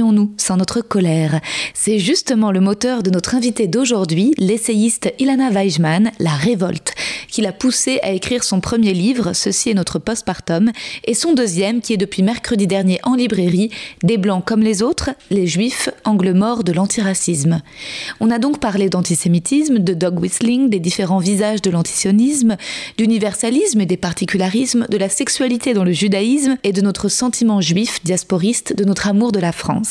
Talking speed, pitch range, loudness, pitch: 170 wpm, 185-235 Hz, -16 LUFS, 210 Hz